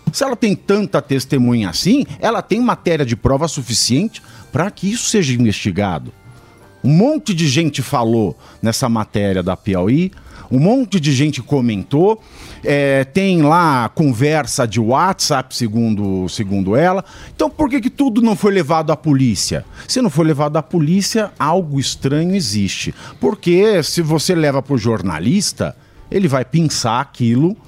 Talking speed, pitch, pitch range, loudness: 150 wpm, 145 Hz, 115-180 Hz, -16 LUFS